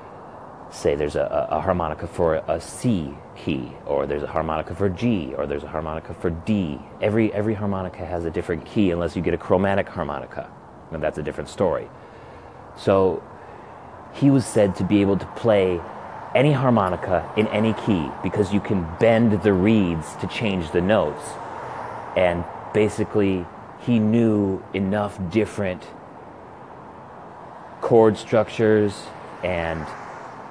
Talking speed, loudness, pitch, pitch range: 140 wpm, -22 LUFS, 95 Hz, 85-110 Hz